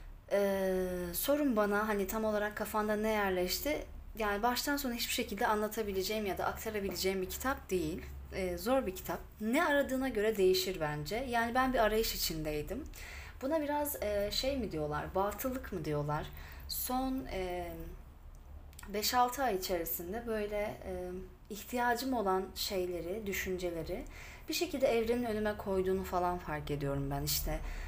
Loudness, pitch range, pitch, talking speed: -35 LUFS, 175-230 Hz, 200 Hz, 140 wpm